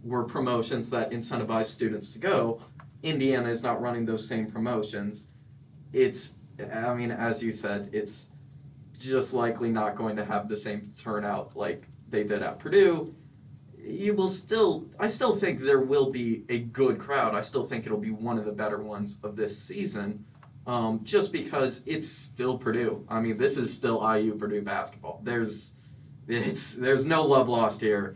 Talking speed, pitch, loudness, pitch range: 175 wpm, 120 Hz, -28 LUFS, 110-135 Hz